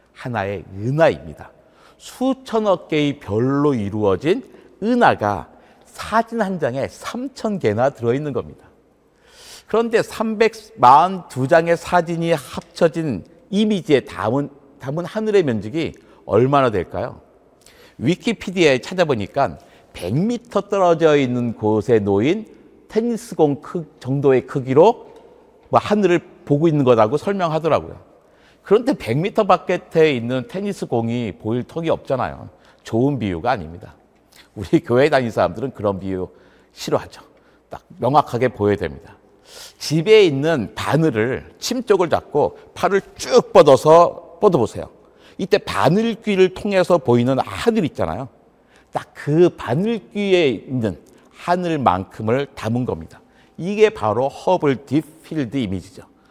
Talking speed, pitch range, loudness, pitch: 270 characters per minute, 125-205 Hz, -19 LUFS, 160 Hz